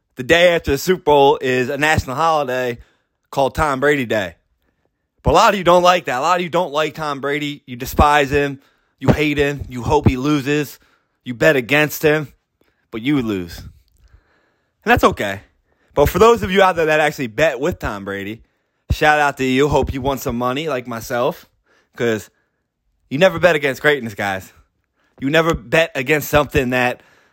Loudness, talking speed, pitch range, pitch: -17 LUFS, 190 wpm, 125-155 Hz, 140 Hz